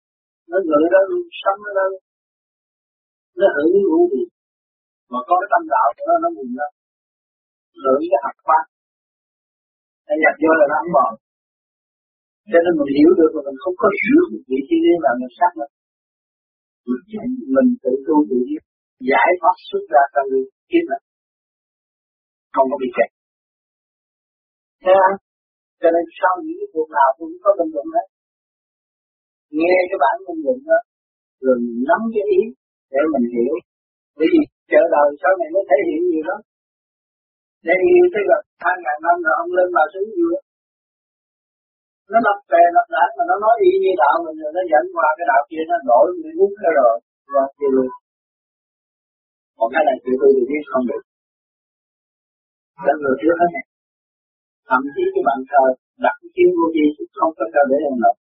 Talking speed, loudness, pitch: 170 wpm, -17 LUFS, 260 Hz